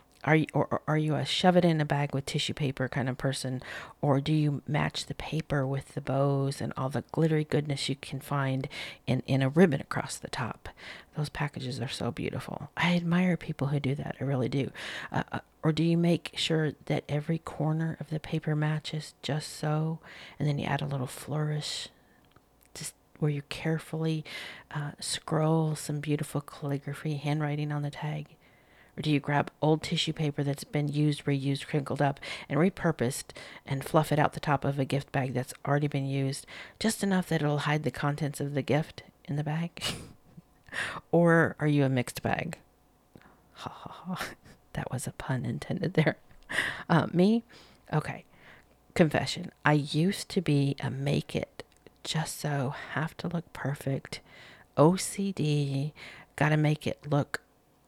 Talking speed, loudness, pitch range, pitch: 175 wpm, -30 LUFS, 140-155 Hz, 145 Hz